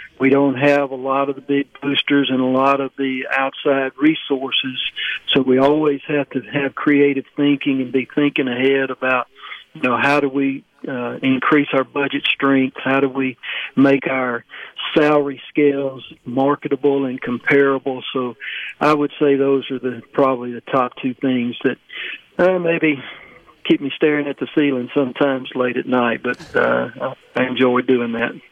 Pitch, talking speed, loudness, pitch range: 135 Hz, 170 wpm, -18 LUFS, 130-145 Hz